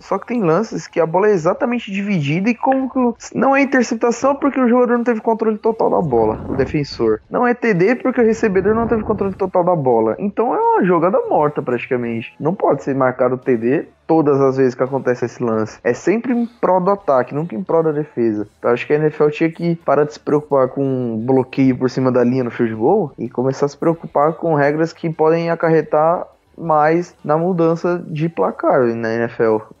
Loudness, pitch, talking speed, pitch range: -17 LUFS, 160 Hz, 210 wpm, 130-210 Hz